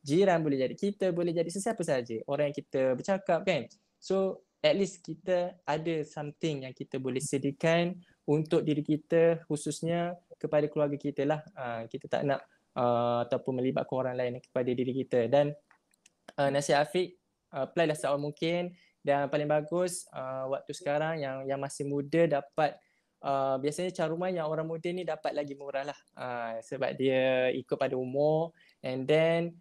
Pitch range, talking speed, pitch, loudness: 135-170 Hz, 165 wpm, 150 Hz, -31 LUFS